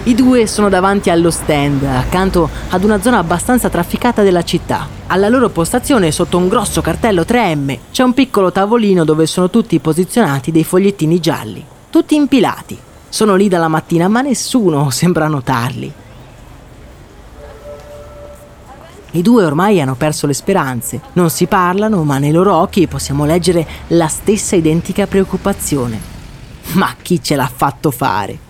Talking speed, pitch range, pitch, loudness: 145 wpm, 155-200 Hz, 175 Hz, -13 LUFS